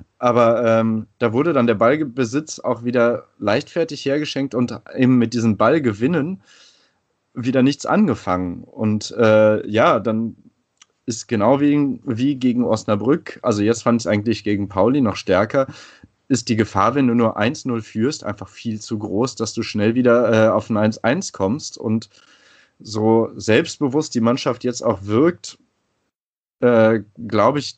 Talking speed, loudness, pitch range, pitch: 155 wpm, -19 LUFS, 110-130 Hz, 115 Hz